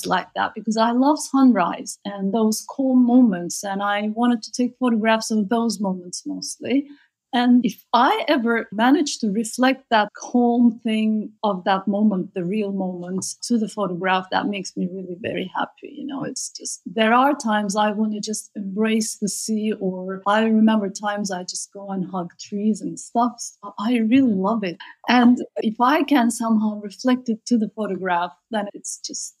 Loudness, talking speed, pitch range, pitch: -21 LUFS, 180 wpm, 200-245 Hz, 220 Hz